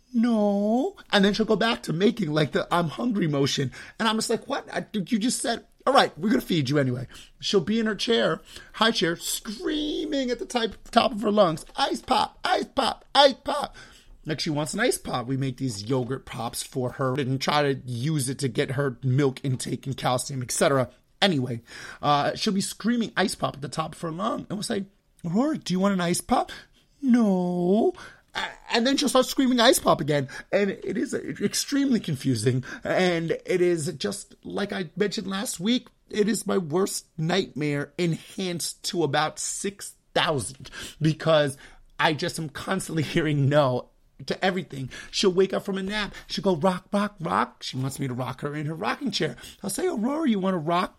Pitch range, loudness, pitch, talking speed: 145-220 Hz, -25 LUFS, 180 Hz, 200 wpm